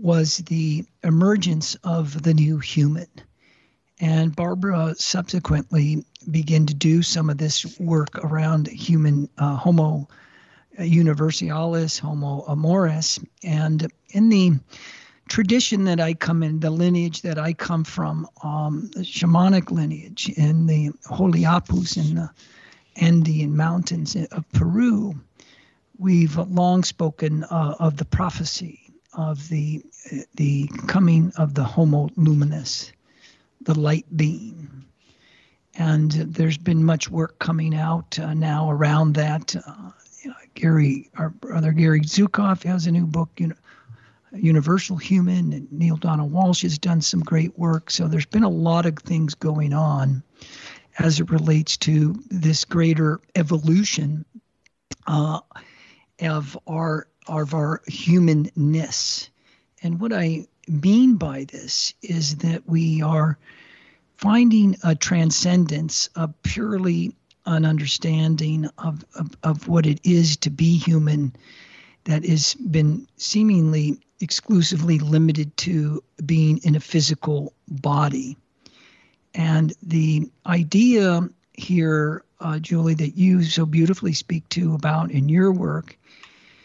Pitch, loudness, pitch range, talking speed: 160 Hz, -21 LUFS, 155-175 Hz, 125 wpm